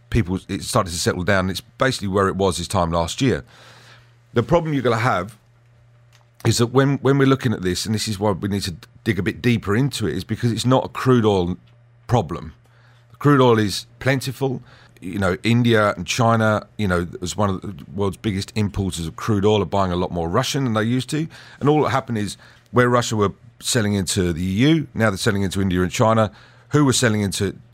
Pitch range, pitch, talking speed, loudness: 100-120 Hz, 110 Hz, 225 wpm, -20 LUFS